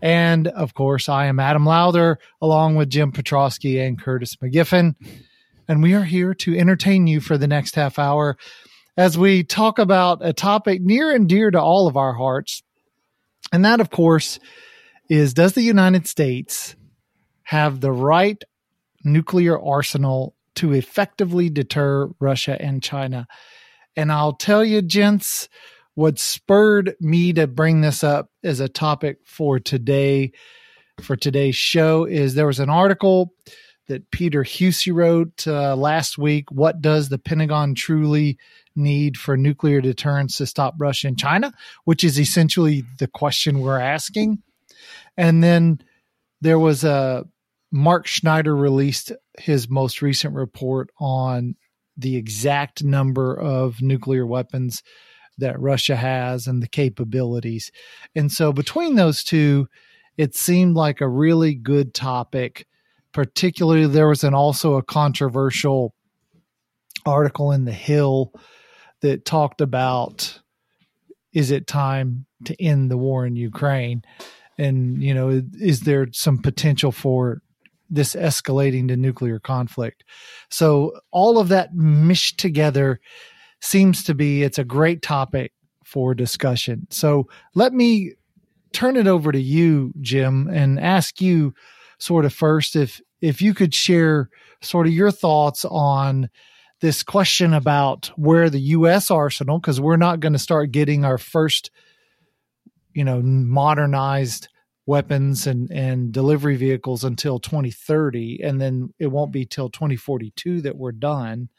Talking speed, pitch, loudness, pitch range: 140 wpm, 150 Hz, -19 LUFS, 135-170 Hz